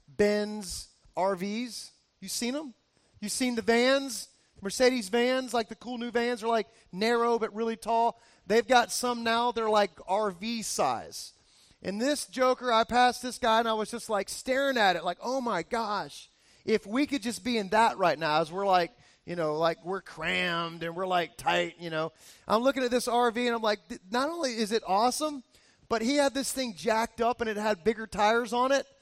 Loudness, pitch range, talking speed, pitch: -28 LUFS, 200-245 Hz, 205 wpm, 230 Hz